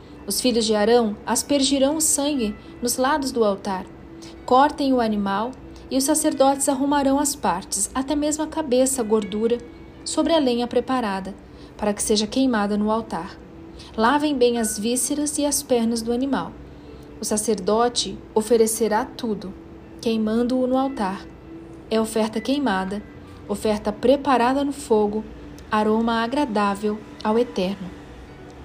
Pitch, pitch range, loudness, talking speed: 235 Hz, 215-270 Hz, -22 LUFS, 130 wpm